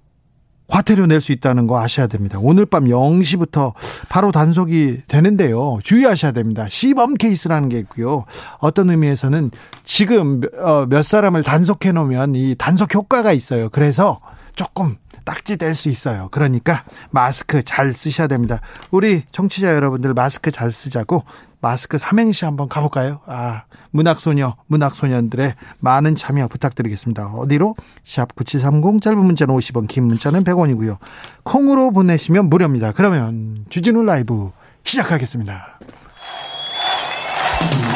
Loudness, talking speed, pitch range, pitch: -16 LUFS, 315 characters per minute, 125-175 Hz, 145 Hz